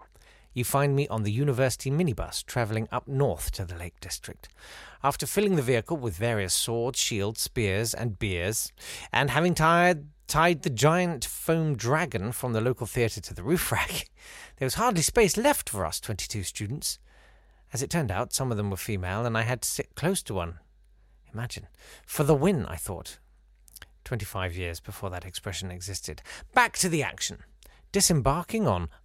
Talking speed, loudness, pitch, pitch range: 175 wpm, -27 LUFS, 120 Hz, 95-150 Hz